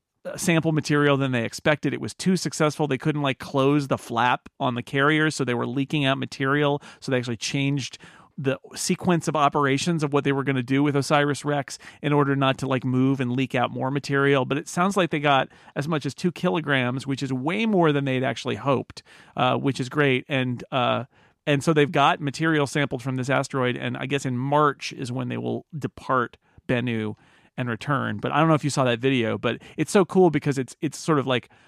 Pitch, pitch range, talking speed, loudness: 140 Hz, 130-150 Hz, 225 wpm, -24 LUFS